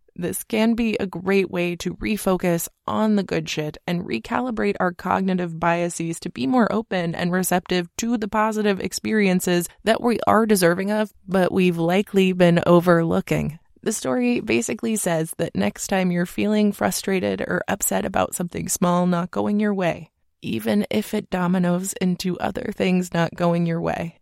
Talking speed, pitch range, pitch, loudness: 165 wpm, 175-210 Hz, 185 Hz, -22 LUFS